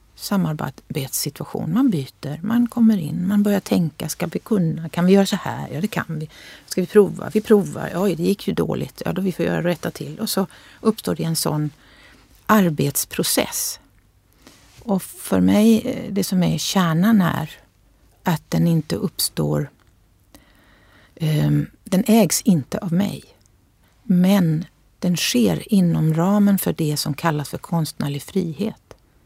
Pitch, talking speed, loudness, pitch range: 175 Hz, 150 wpm, -20 LUFS, 150-200 Hz